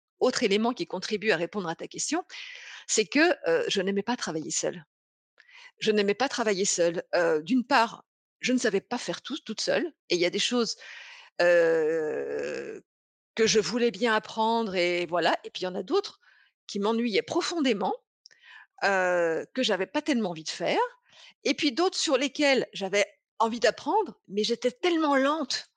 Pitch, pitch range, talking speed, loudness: 245 Hz, 205-345 Hz, 180 wpm, -27 LUFS